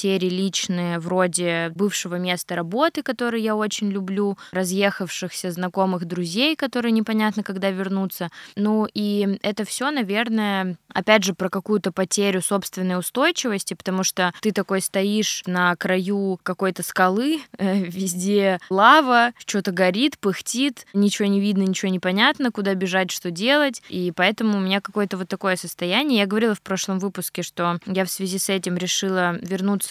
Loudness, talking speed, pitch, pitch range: -22 LUFS, 150 wpm, 195 Hz, 185-210 Hz